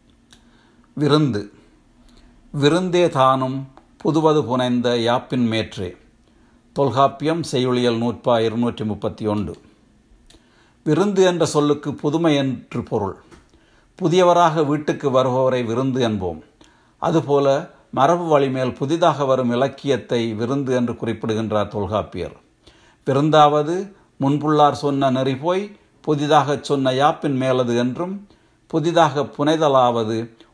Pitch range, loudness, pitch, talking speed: 120-150 Hz, -19 LUFS, 135 Hz, 90 wpm